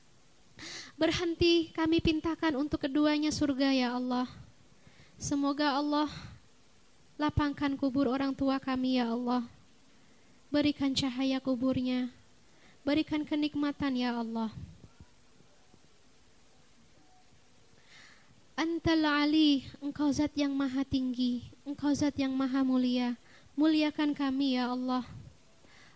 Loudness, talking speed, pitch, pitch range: -31 LUFS, 90 wpm, 280 Hz, 260-300 Hz